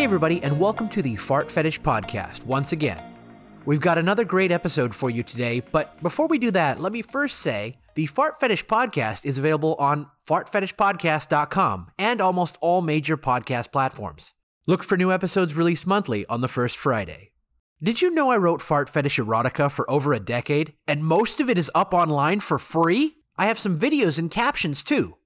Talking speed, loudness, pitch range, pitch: 190 wpm, -23 LUFS, 140-190 Hz, 160 Hz